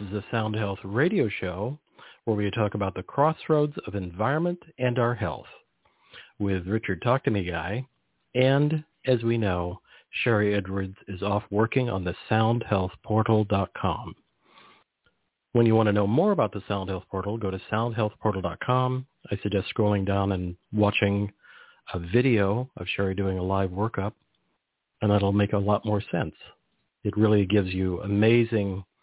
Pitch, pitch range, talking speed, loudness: 105 Hz, 95-115 Hz, 155 wpm, -26 LUFS